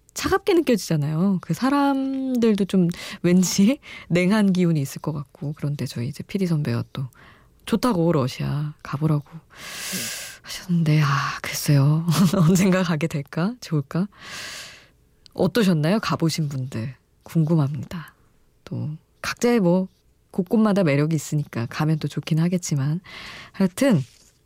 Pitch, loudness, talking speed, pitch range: 165 Hz, -22 LUFS, 270 characters per minute, 150-195 Hz